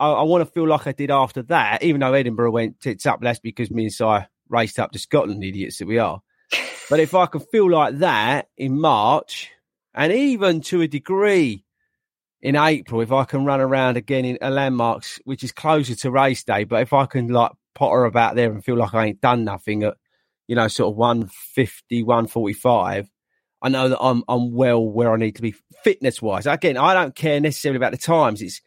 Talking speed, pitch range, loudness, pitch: 220 wpm, 115-145 Hz, -20 LUFS, 130 Hz